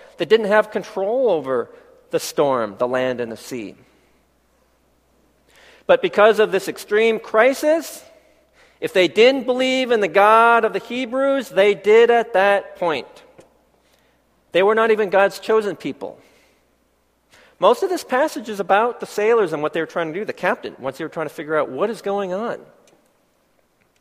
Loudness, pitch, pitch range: -18 LUFS, 210 Hz, 175-255 Hz